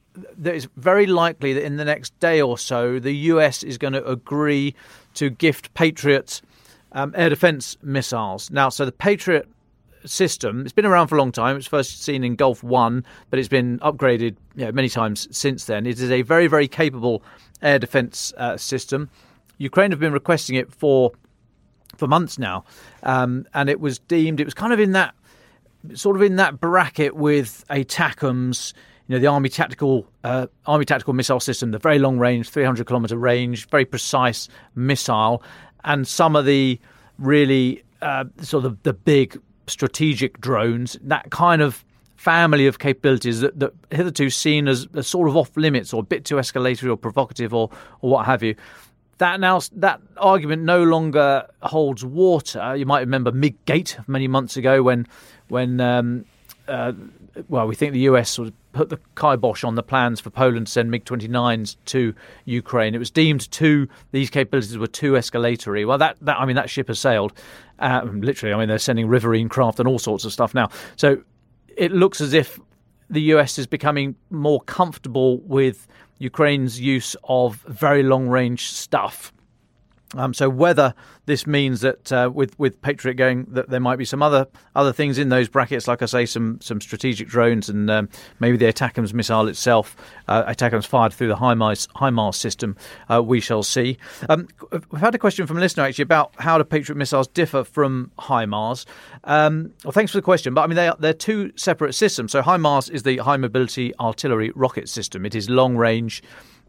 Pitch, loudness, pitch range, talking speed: 135 Hz, -20 LUFS, 120-150 Hz, 185 wpm